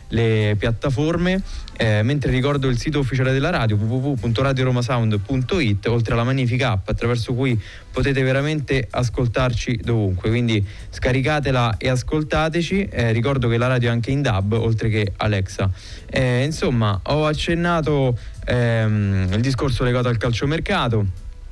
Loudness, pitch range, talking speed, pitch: -20 LUFS, 110-135 Hz, 130 wpm, 125 Hz